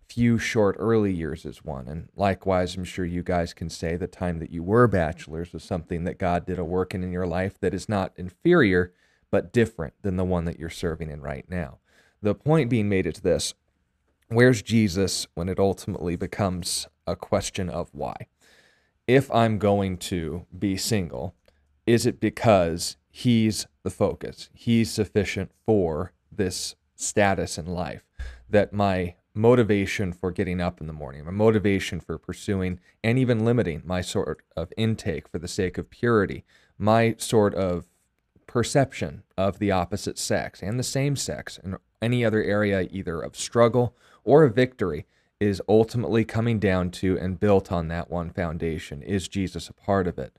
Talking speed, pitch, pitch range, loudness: 175 wpm, 95 Hz, 85-110 Hz, -25 LUFS